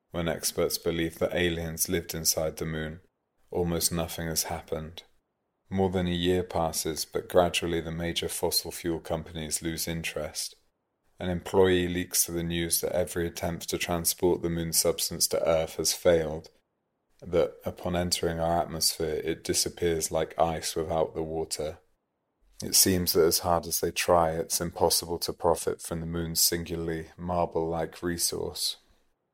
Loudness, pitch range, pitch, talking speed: -28 LUFS, 80-90 Hz, 85 Hz, 155 wpm